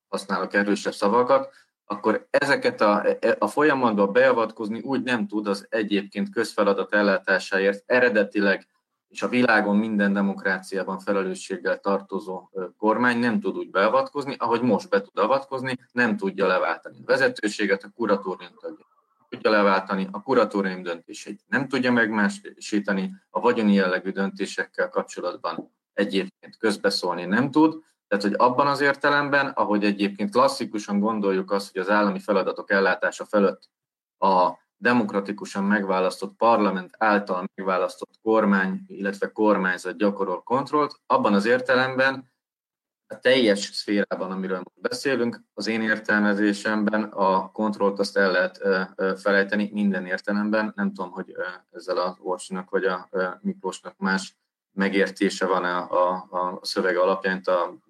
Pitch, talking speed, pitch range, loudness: 105 Hz, 125 wpm, 95-115 Hz, -23 LUFS